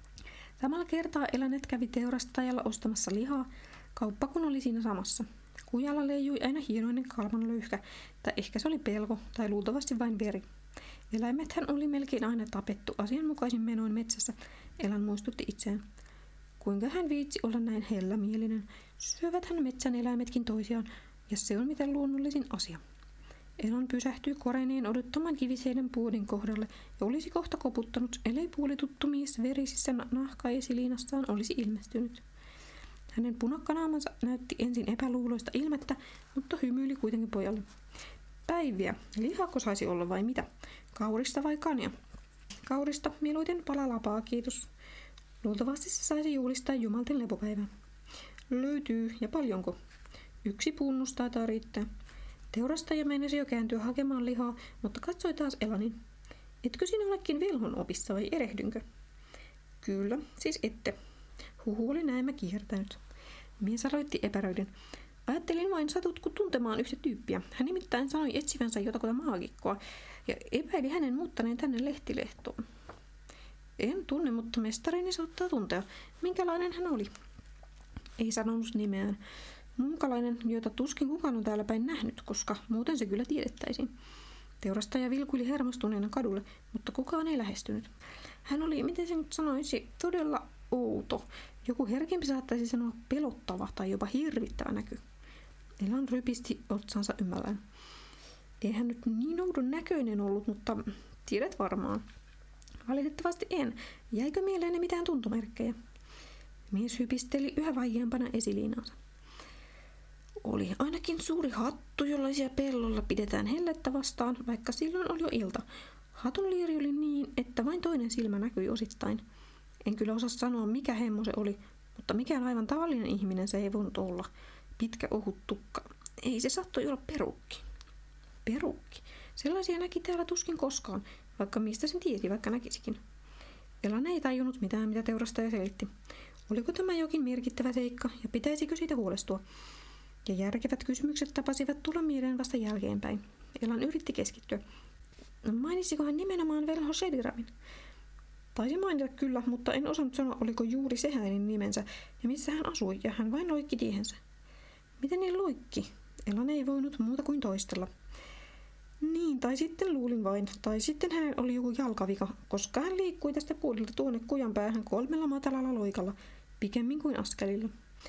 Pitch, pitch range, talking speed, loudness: 250 Hz, 225-290 Hz, 135 wpm, -34 LUFS